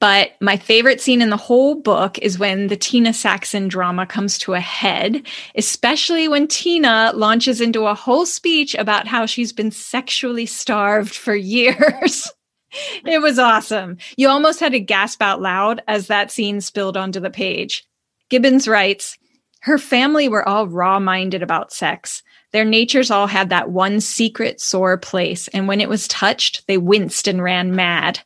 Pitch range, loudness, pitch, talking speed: 195-255 Hz, -16 LUFS, 215 Hz, 170 wpm